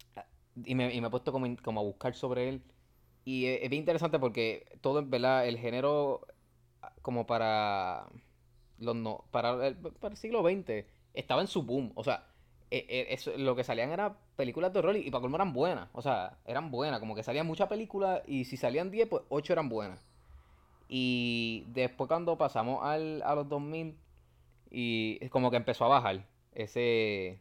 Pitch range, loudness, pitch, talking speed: 110-145 Hz, -33 LUFS, 125 Hz, 190 wpm